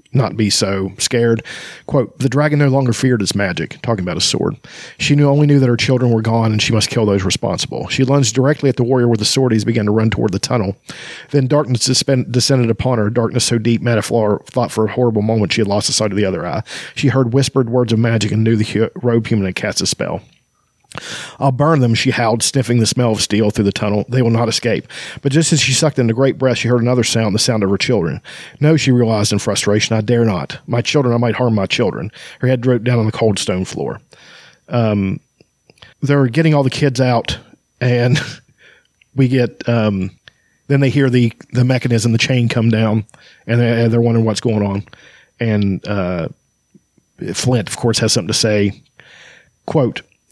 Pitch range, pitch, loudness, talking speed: 110-130 Hz, 120 Hz, -15 LUFS, 220 wpm